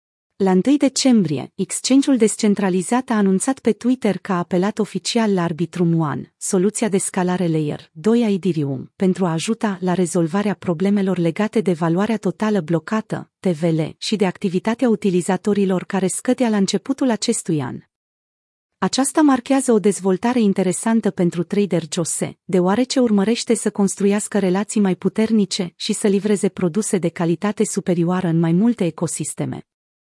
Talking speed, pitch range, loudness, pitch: 140 wpm, 180-220 Hz, -19 LUFS, 195 Hz